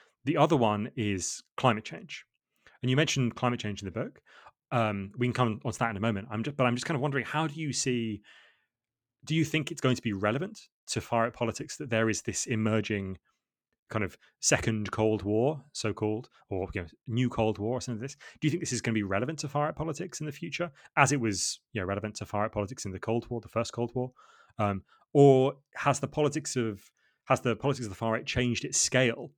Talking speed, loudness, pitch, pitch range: 245 wpm, -30 LUFS, 120 Hz, 110-140 Hz